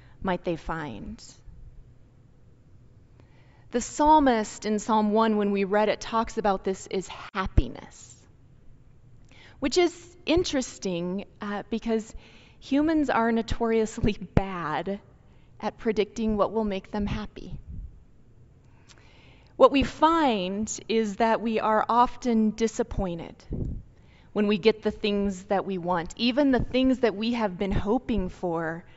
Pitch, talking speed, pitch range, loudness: 210 Hz, 120 wpm, 185-230 Hz, -26 LUFS